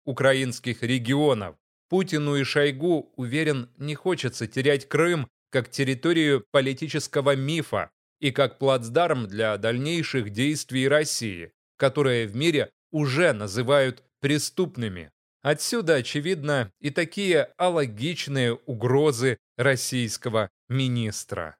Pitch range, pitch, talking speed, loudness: 125-150 Hz, 140 Hz, 95 wpm, -25 LUFS